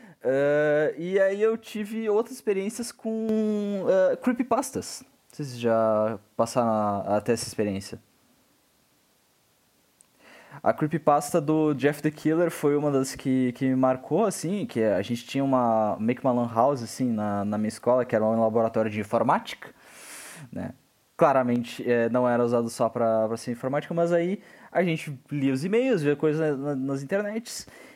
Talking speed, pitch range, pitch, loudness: 165 wpm, 115-175 Hz, 135 Hz, -25 LUFS